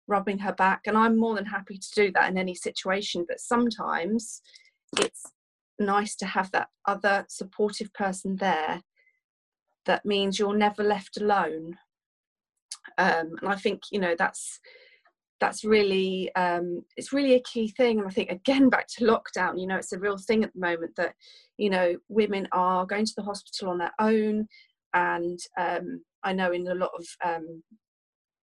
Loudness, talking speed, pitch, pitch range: -27 LUFS, 175 wpm, 200 Hz, 185-220 Hz